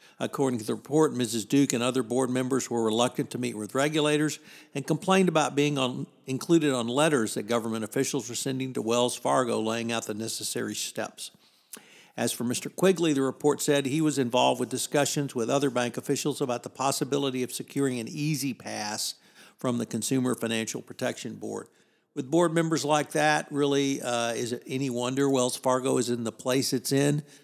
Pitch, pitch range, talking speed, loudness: 130 Hz, 120-145 Hz, 190 wpm, -27 LUFS